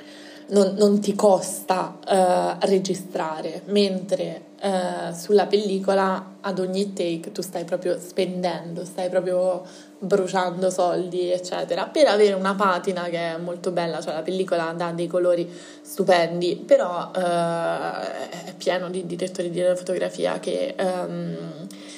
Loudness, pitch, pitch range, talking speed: -23 LUFS, 185 Hz, 175-195 Hz, 130 wpm